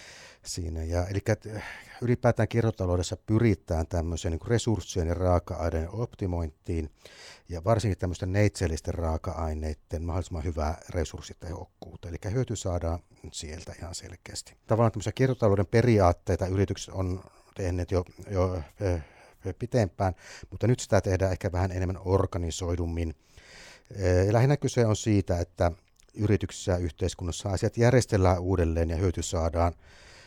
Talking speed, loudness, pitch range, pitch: 120 wpm, -28 LUFS, 85-105 Hz, 90 Hz